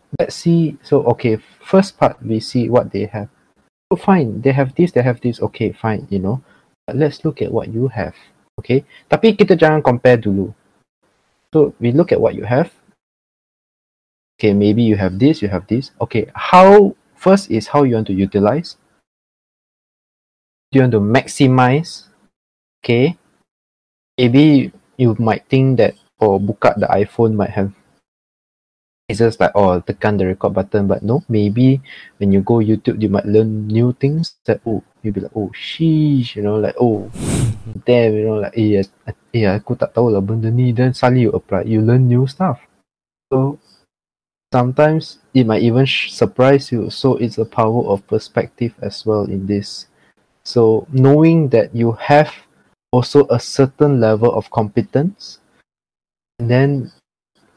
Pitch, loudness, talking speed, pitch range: 120 Hz, -15 LUFS, 160 wpm, 105-135 Hz